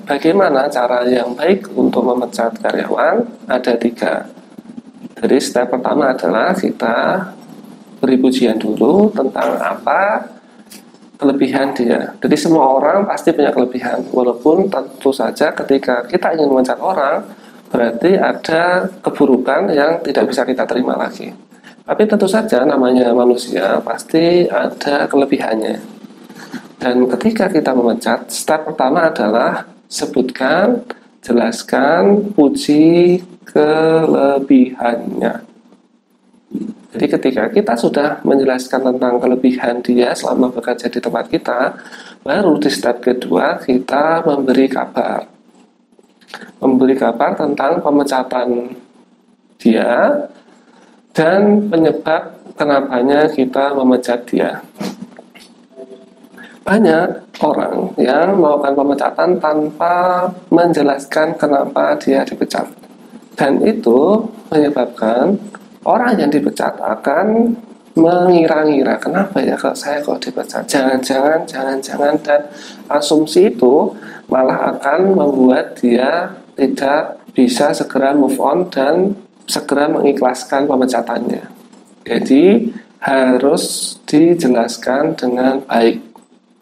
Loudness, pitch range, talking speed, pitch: -14 LUFS, 125-180 Hz, 100 wpm, 145 Hz